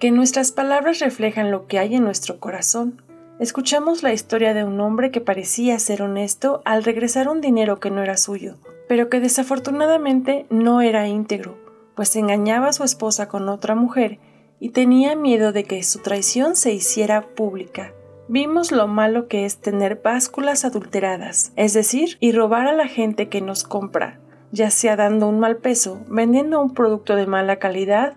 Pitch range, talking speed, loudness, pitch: 205-255 Hz, 175 wpm, -19 LUFS, 220 Hz